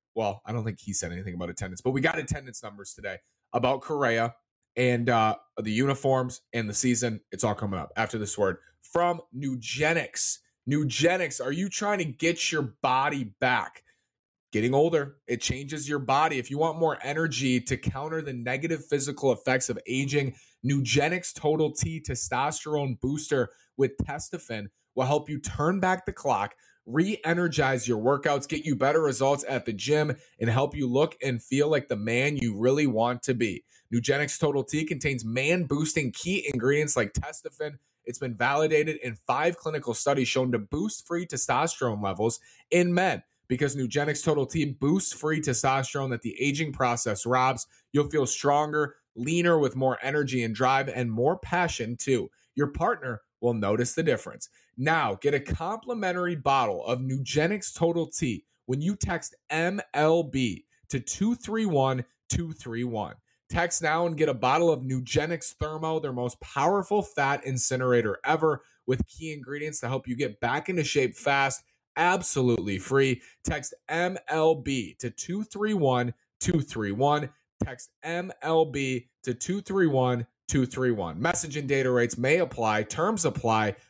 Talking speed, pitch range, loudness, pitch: 150 wpm, 120-155 Hz, -27 LUFS, 135 Hz